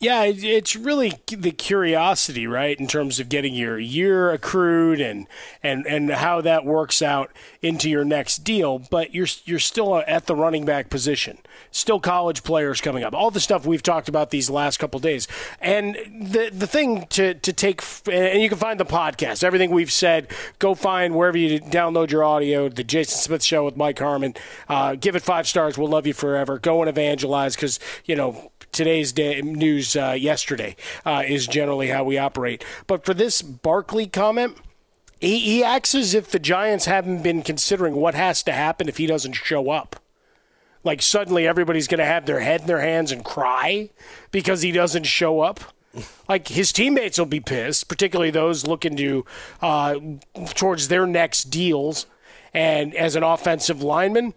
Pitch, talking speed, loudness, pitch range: 165 Hz, 185 wpm, -21 LUFS, 145-190 Hz